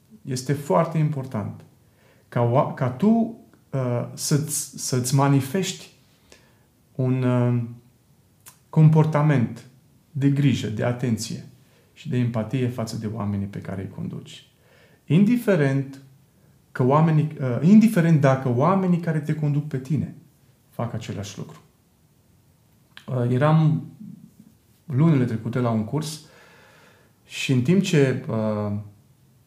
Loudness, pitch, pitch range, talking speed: -22 LUFS, 135 Hz, 120-155 Hz, 110 wpm